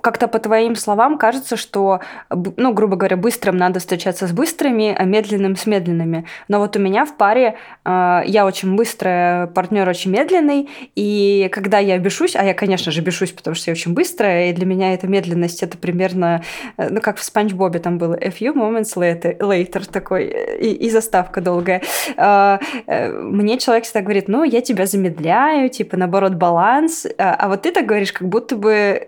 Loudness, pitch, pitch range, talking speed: -17 LUFS, 200 Hz, 185-225 Hz, 190 wpm